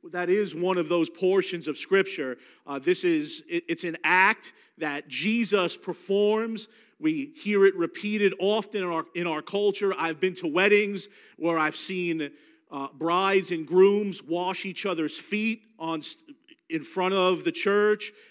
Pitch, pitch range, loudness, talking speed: 190 Hz, 170-210 Hz, -26 LUFS, 160 wpm